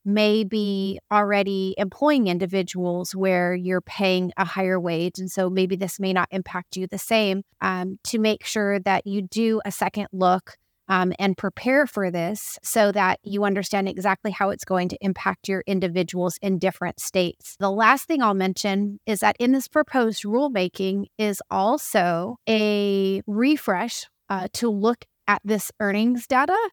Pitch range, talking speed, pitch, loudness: 185-215 Hz, 165 wpm, 195 Hz, -23 LUFS